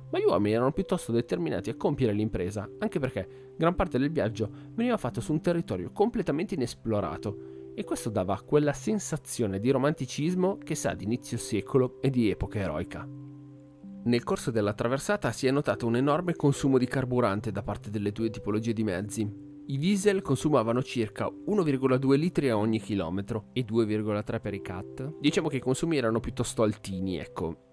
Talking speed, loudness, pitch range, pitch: 170 wpm, -29 LUFS, 105-145 Hz, 120 Hz